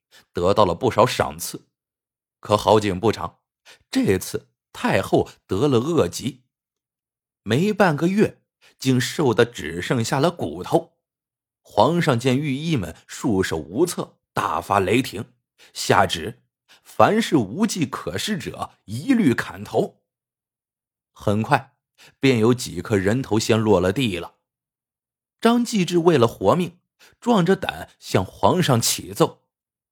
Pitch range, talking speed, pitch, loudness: 105-165 Hz, 175 characters per minute, 130 Hz, -21 LUFS